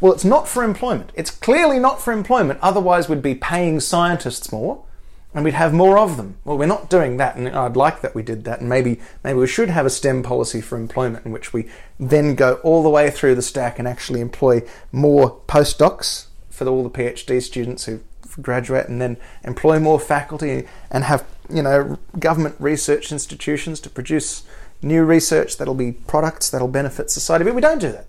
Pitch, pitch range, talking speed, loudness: 140 Hz, 125-160 Hz, 205 wpm, -18 LUFS